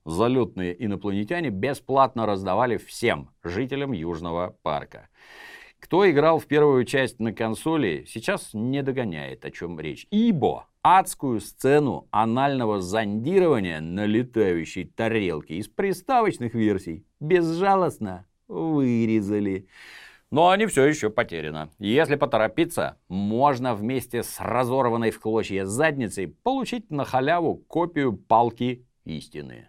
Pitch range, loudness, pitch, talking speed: 100-145 Hz, -24 LUFS, 115 Hz, 110 wpm